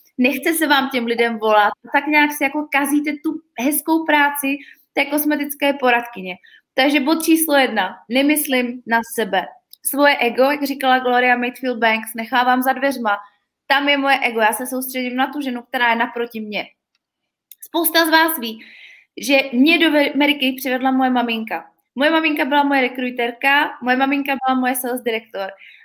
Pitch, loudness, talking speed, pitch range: 265 Hz, -17 LUFS, 160 wpm, 240-290 Hz